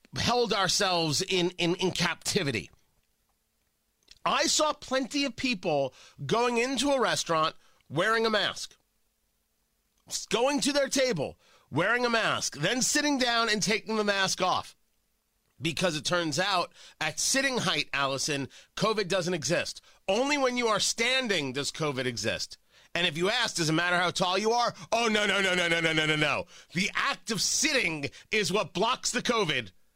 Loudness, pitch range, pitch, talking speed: -27 LUFS, 165-235 Hz, 190 Hz, 165 wpm